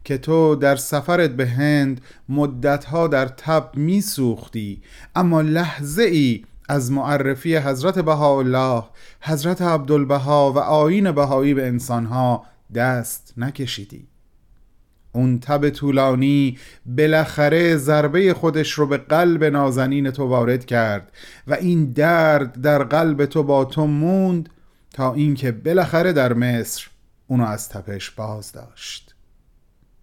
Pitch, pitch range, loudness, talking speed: 140 Hz, 125-155 Hz, -19 LUFS, 115 wpm